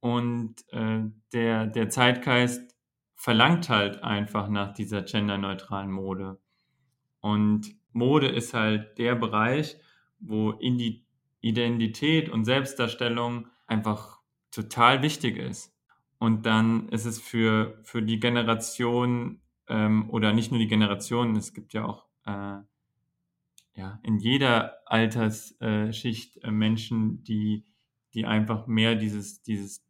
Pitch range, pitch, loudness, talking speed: 105-120 Hz, 115 Hz, -26 LUFS, 120 wpm